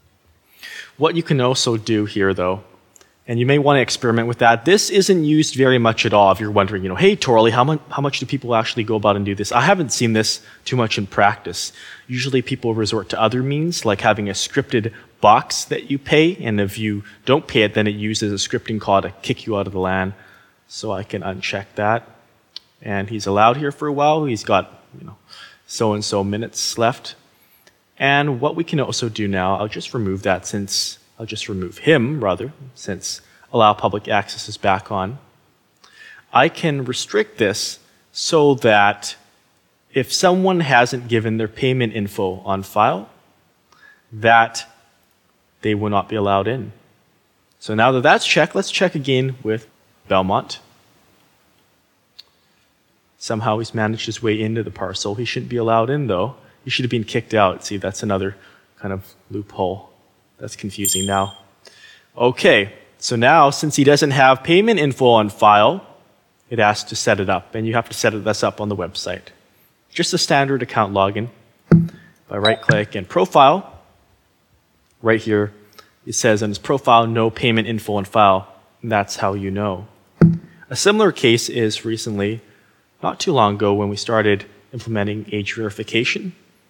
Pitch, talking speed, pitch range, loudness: 110 Hz, 180 wpm, 100-125 Hz, -18 LUFS